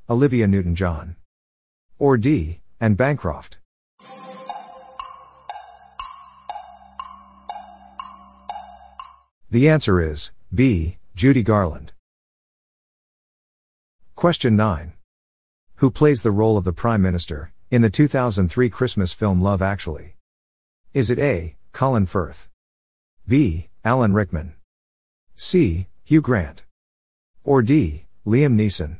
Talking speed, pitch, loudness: 90 wpm, 100 Hz, -20 LUFS